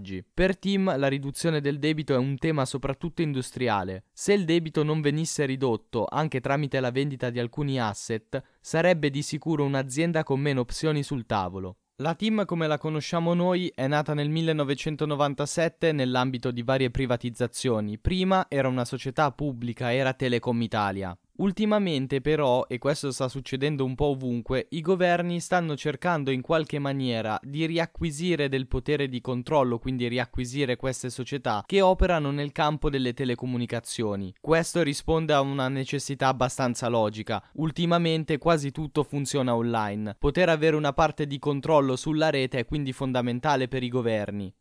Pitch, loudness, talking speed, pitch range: 140 Hz, -27 LUFS, 150 wpm, 125-155 Hz